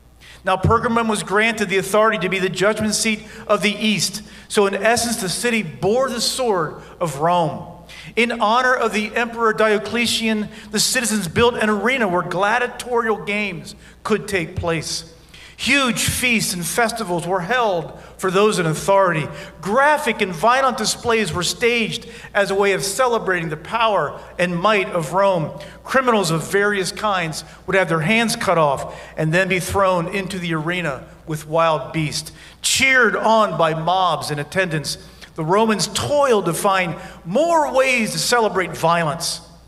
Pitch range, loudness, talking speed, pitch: 175-225 Hz, -18 LUFS, 155 wpm, 195 Hz